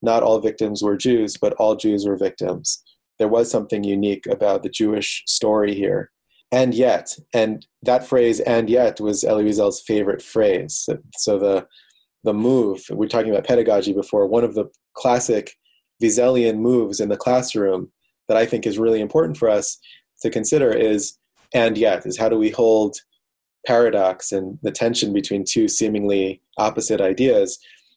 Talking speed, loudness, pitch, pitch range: 165 wpm, -19 LUFS, 110 Hz, 100-115 Hz